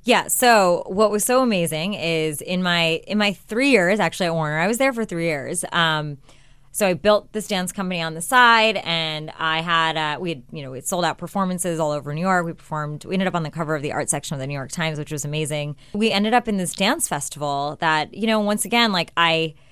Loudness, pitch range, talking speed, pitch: -21 LUFS, 155-200 Hz, 250 wpm, 170 Hz